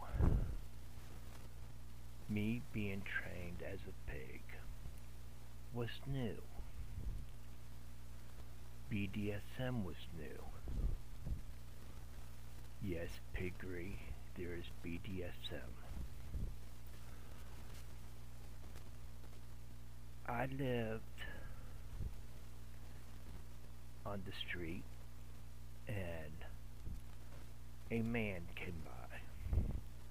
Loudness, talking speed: -48 LUFS, 50 wpm